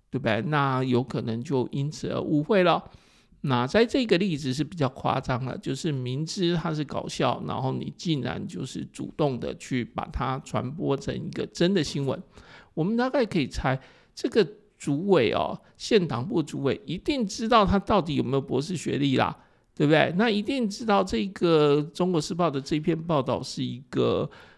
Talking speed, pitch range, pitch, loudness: 270 characters per minute, 130-195 Hz, 155 Hz, -26 LUFS